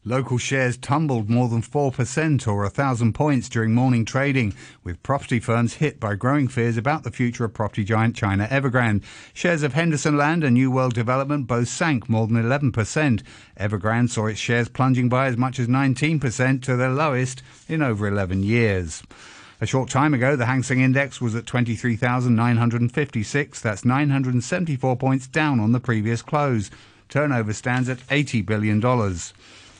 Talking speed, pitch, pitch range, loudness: 165 wpm, 125 Hz, 115-135 Hz, -22 LUFS